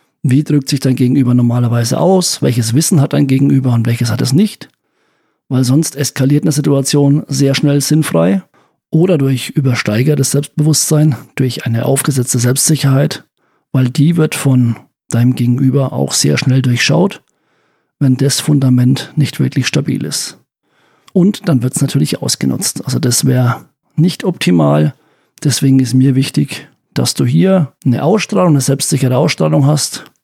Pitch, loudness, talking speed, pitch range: 135 Hz, -12 LUFS, 145 wpm, 125-150 Hz